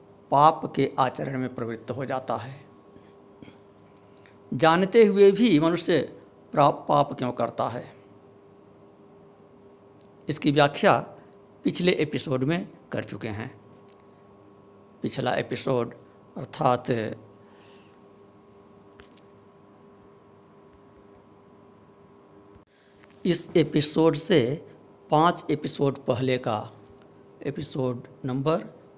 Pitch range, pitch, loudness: 100-140 Hz, 100 Hz, -25 LUFS